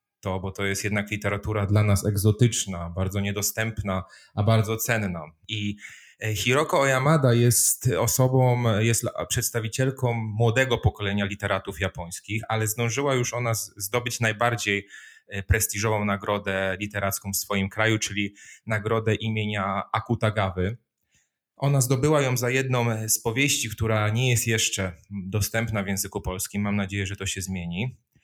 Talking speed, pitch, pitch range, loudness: 130 wpm, 105 Hz, 100-115 Hz, -25 LUFS